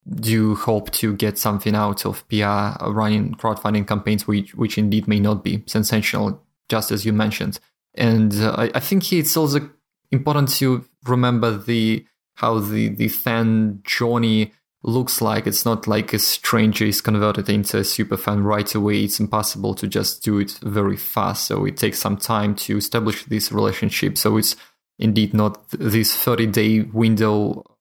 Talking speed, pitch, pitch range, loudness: 170 wpm, 110 Hz, 105-115 Hz, -20 LUFS